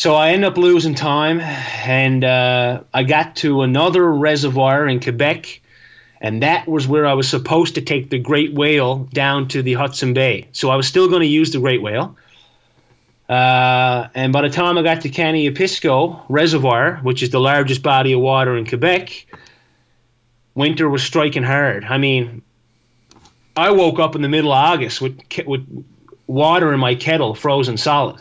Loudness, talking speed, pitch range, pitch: -16 LUFS, 180 wpm, 125-155 Hz, 140 Hz